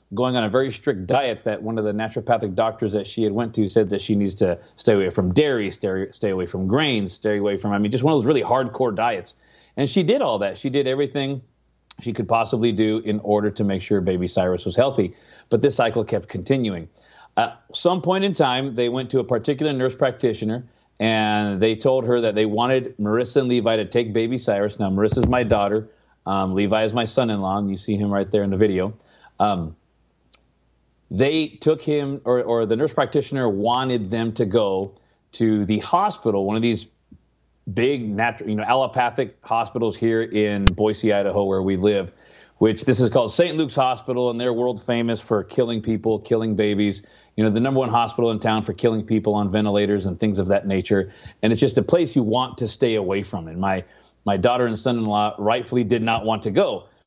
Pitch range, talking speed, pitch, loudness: 100-125 Hz, 215 wpm, 110 Hz, -21 LUFS